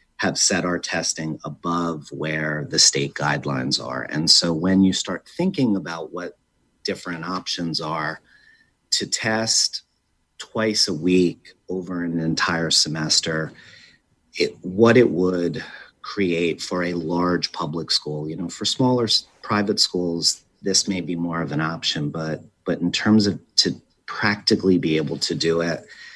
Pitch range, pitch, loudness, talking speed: 80-95 Hz, 85 Hz, -21 LUFS, 150 wpm